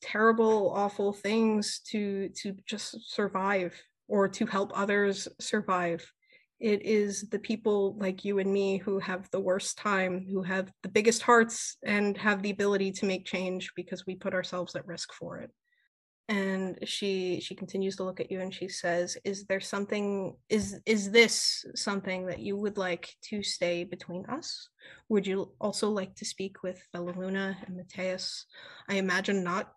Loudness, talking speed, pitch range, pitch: -30 LUFS, 170 wpm, 185-210 Hz, 195 Hz